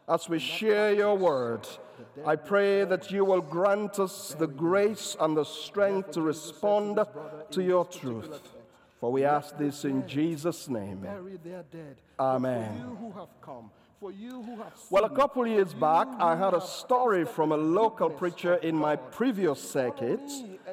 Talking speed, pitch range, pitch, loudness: 140 wpm, 155-200 Hz, 180 Hz, -28 LUFS